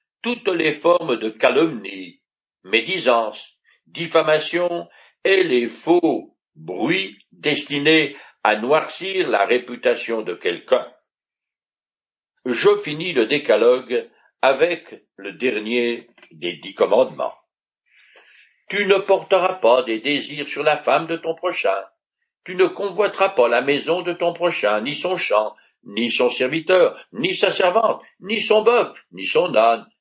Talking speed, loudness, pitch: 130 wpm, -20 LUFS, 185 Hz